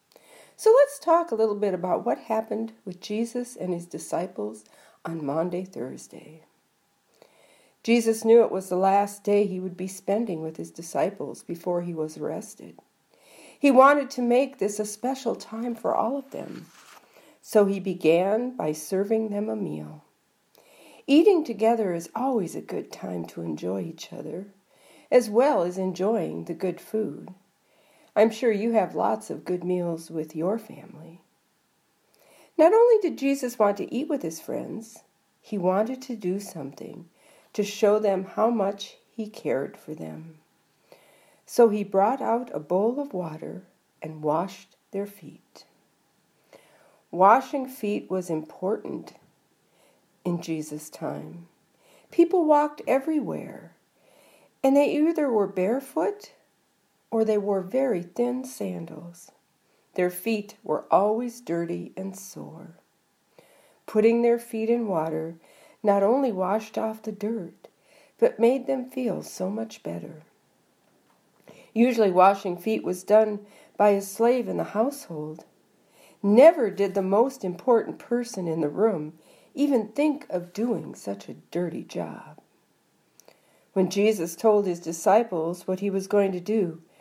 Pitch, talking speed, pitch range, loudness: 205 Hz, 140 wpm, 180-240 Hz, -25 LUFS